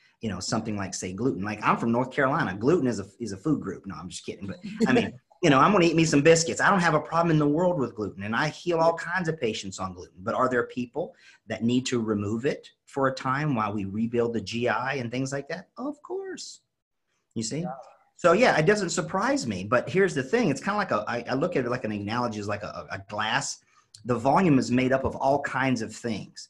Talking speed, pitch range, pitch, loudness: 265 wpm, 115-165 Hz, 130 Hz, -26 LUFS